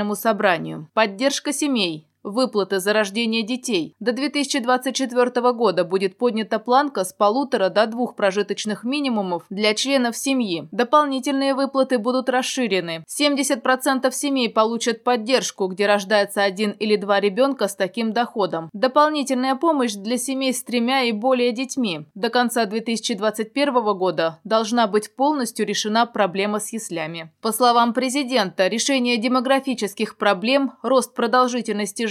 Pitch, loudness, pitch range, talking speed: 235 Hz, -21 LUFS, 205-260 Hz, 125 wpm